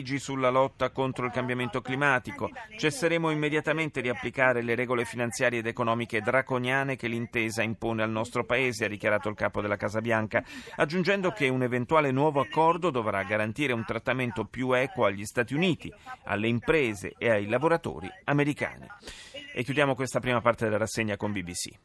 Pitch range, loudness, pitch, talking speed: 115-135 Hz, -28 LUFS, 125 Hz, 160 wpm